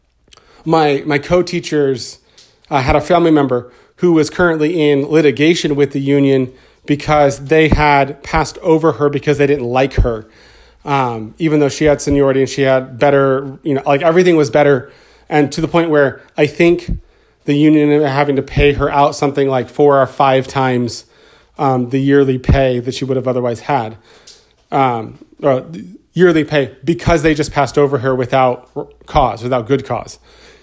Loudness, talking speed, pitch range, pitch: -14 LUFS, 180 wpm, 135-155 Hz, 145 Hz